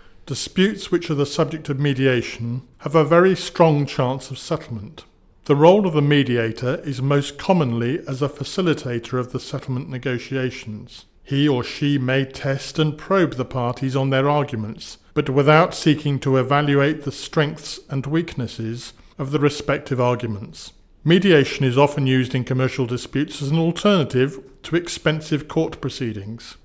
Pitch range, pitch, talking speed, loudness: 125-155 Hz, 140 Hz, 155 wpm, -20 LUFS